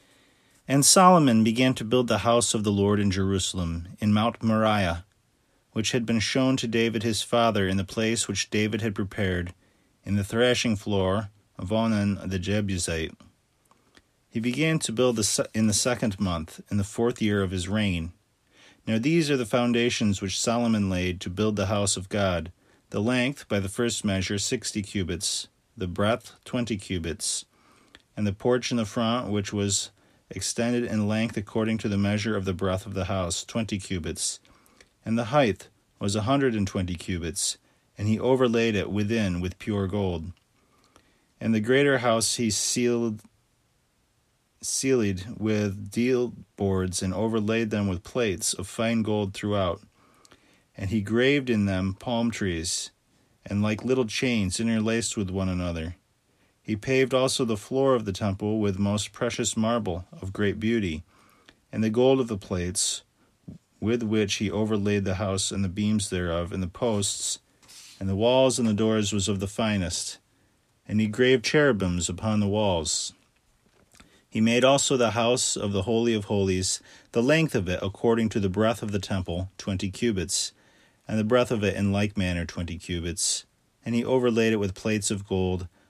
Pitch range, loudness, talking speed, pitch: 95-115 Hz, -26 LUFS, 170 wpm, 105 Hz